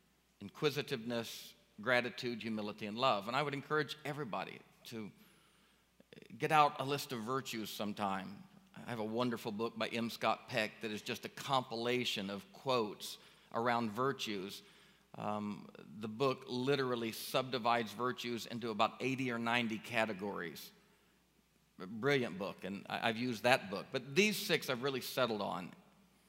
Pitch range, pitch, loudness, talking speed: 115-135 Hz, 120 Hz, -37 LUFS, 145 wpm